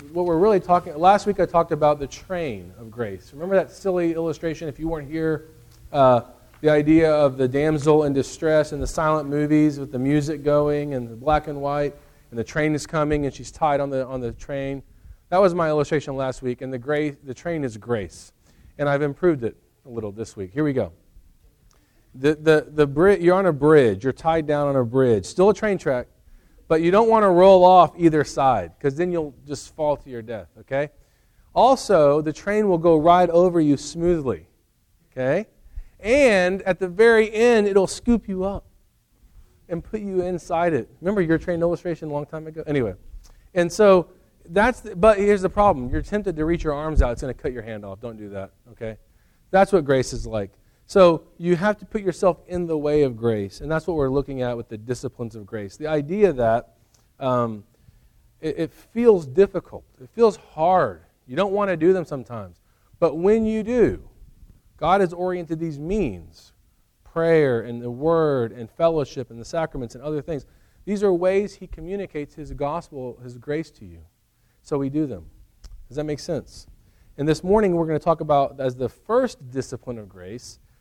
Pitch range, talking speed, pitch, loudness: 125-175 Hz, 205 wpm, 150 Hz, -21 LUFS